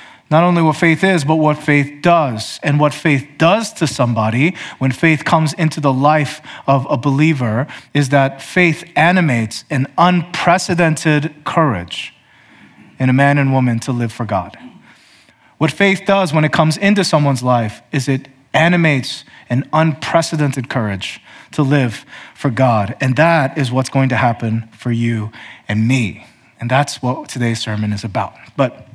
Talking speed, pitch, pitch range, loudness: 160 wpm, 140 Hz, 125-160 Hz, -15 LUFS